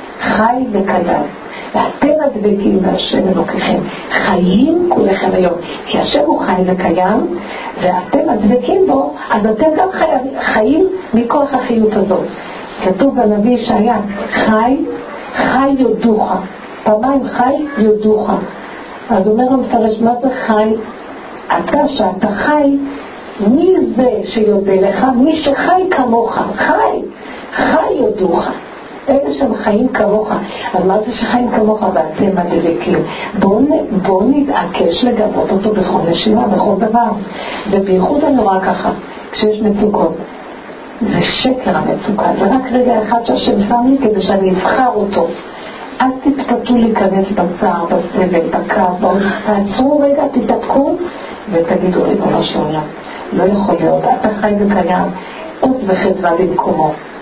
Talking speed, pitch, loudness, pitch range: 120 wpm, 220 Hz, -13 LUFS, 195-255 Hz